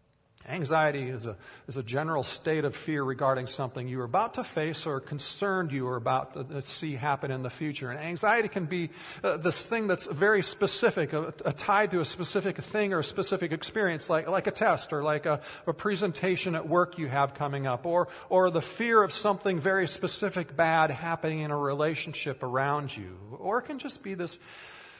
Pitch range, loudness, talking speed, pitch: 140-190 Hz, -29 LUFS, 200 wpm, 160 Hz